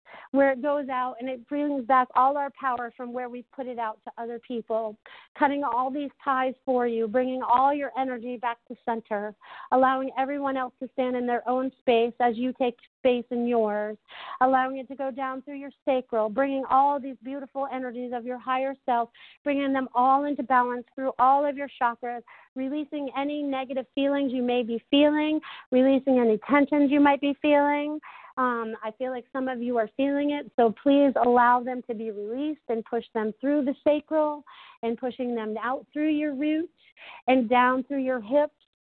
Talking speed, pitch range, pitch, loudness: 195 wpm, 245-280 Hz, 260 Hz, -26 LUFS